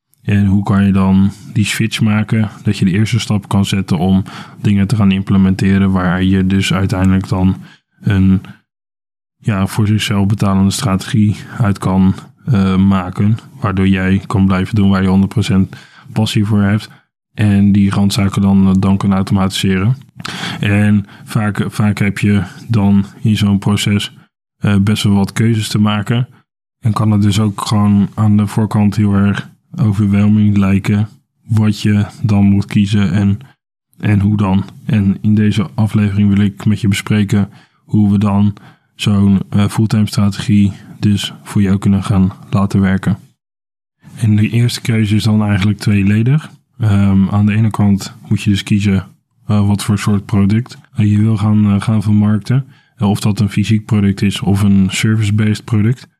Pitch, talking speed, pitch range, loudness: 105 Hz, 165 wpm, 100-110 Hz, -14 LUFS